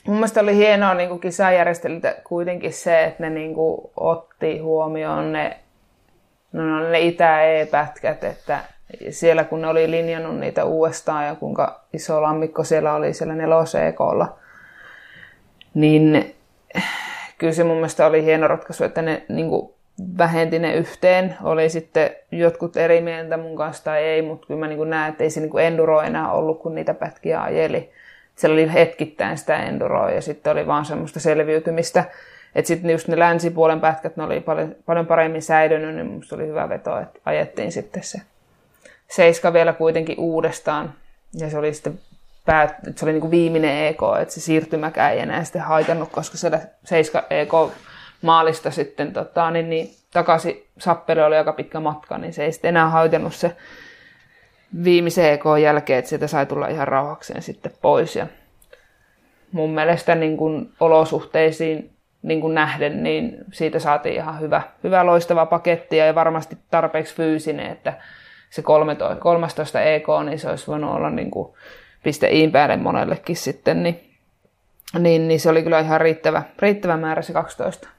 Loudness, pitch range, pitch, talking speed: -19 LUFS, 155-170 Hz, 160 Hz, 160 wpm